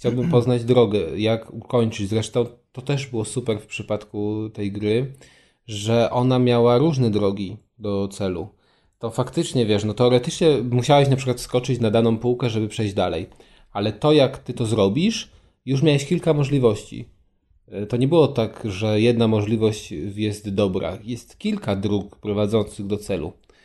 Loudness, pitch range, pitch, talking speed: -21 LUFS, 105-125 Hz, 115 Hz, 155 wpm